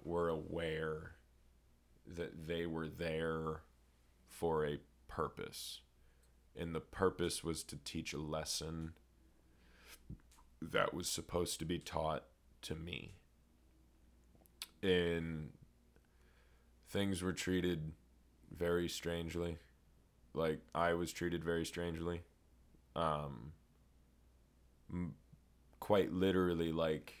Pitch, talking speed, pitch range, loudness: 80 Hz, 95 wpm, 60-85 Hz, -40 LUFS